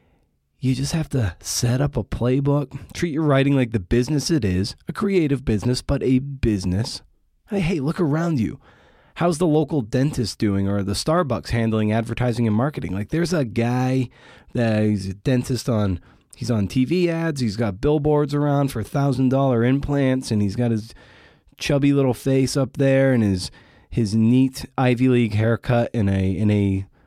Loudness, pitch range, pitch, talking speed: -21 LUFS, 110-140 Hz, 125 Hz, 175 wpm